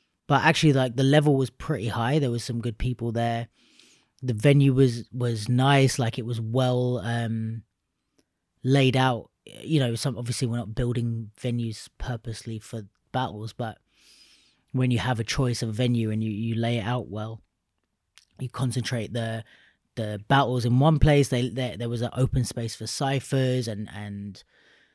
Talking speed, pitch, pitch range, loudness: 170 wpm, 120 Hz, 115-130 Hz, -25 LUFS